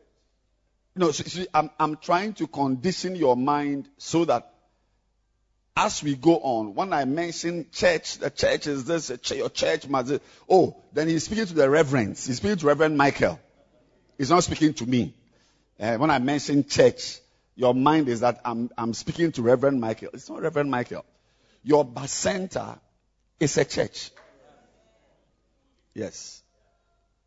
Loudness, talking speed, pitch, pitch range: -24 LUFS, 160 wpm, 145 Hz, 125-165 Hz